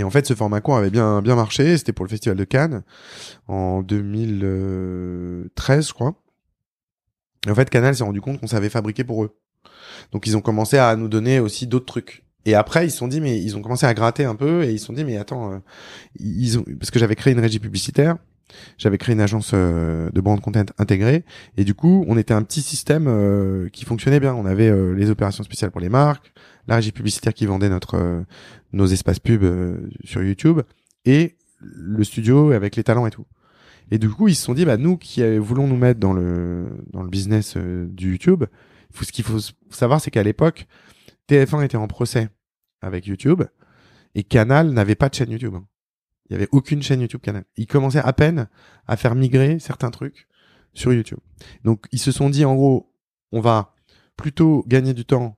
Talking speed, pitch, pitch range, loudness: 205 wpm, 115 Hz, 100-135 Hz, -19 LUFS